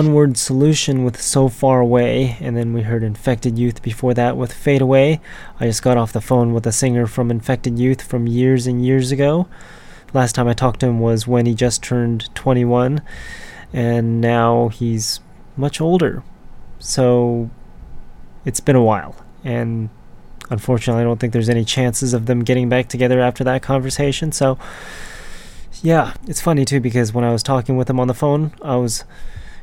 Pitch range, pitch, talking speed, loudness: 120-130 Hz, 125 Hz, 185 wpm, -17 LUFS